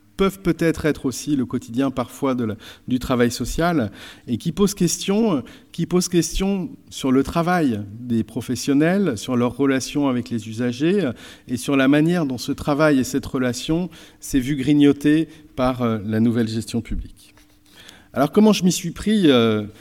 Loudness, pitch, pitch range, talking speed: -21 LUFS, 135 Hz, 120-165 Hz, 165 wpm